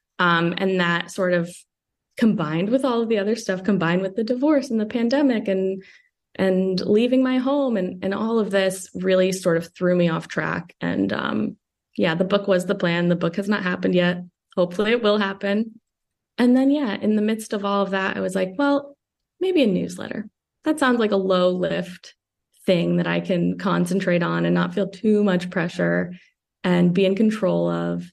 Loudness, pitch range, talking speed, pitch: -22 LUFS, 180-220 Hz, 200 wpm, 190 Hz